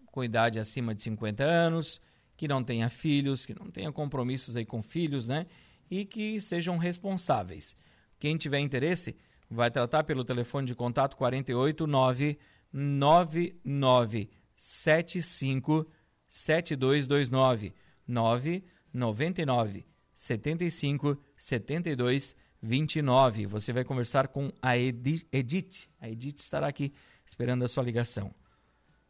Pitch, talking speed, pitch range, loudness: 135 Hz, 110 wpm, 120-155 Hz, -30 LUFS